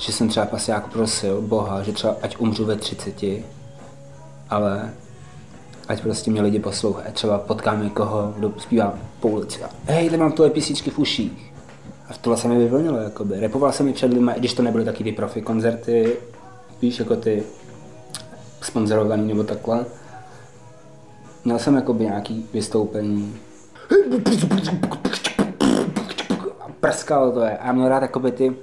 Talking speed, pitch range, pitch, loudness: 145 wpm, 105-125 Hz, 115 Hz, -21 LUFS